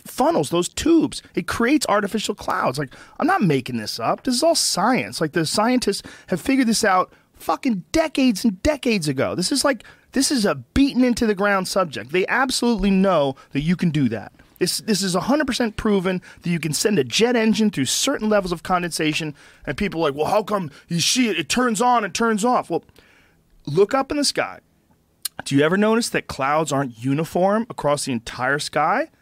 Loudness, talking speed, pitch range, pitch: -20 LUFS, 205 wpm, 165-245 Hz, 205 Hz